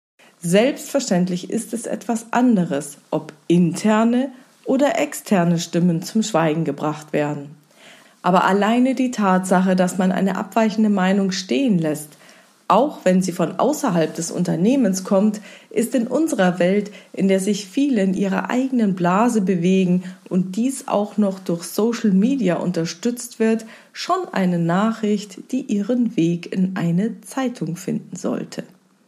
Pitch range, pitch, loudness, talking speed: 180-230 Hz, 200 Hz, -20 LUFS, 135 wpm